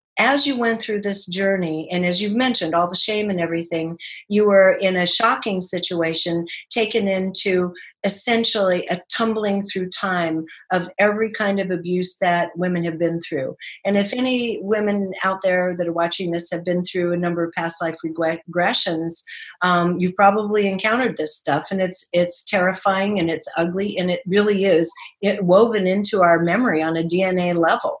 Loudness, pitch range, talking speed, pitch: -20 LUFS, 170-200 Hz, 180 wpm, 185 Hz